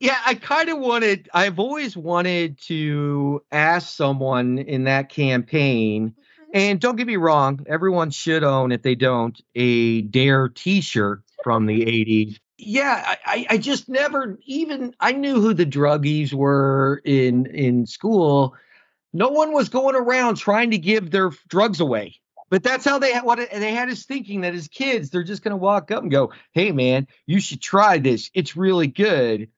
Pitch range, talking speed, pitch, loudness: 135-220 Hz, 175 wpm, 175 Hz, -20 LUFS